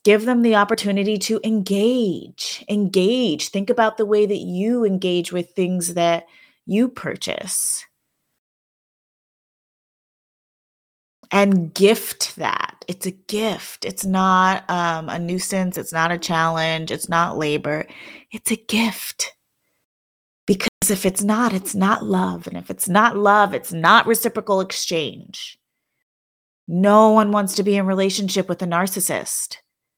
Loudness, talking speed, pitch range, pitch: -19 LUFS, 130 wpm, 175-215 Hz, 195 Hz